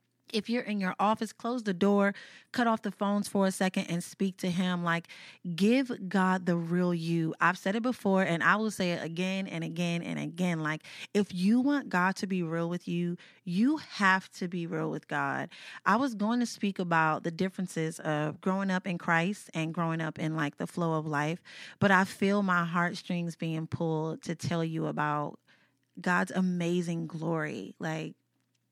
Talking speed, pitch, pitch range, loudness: 195 wpm, 180 Hz, 165-200 Hz, -30 LUFS